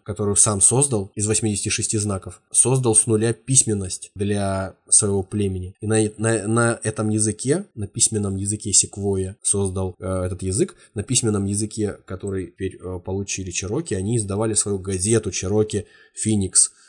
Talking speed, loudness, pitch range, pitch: 140 wpm, -20 LUFS, 95-110 Hz, 105 Hz